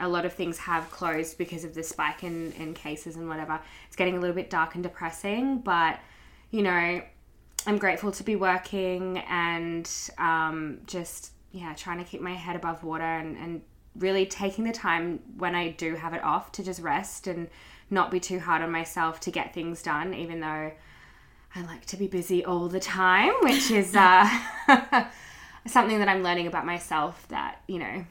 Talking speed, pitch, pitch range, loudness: 190 wpm, 175 Hz, 165-190 Hz, -27 LUFS